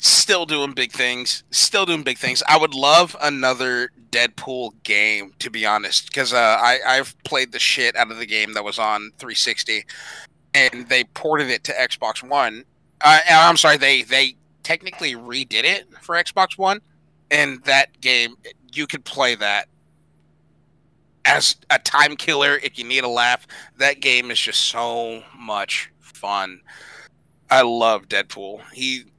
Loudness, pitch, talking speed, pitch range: -18 LUFS, 130 Hz, 160 wpm, 115-150 Hz